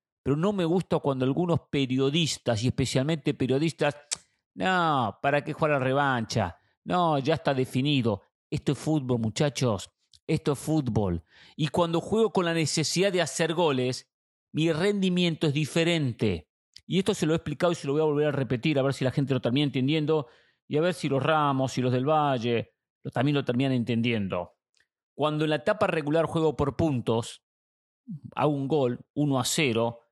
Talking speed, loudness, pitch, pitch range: 185 wpm, -27 LUFS, 145 Hz, 125-160 Hz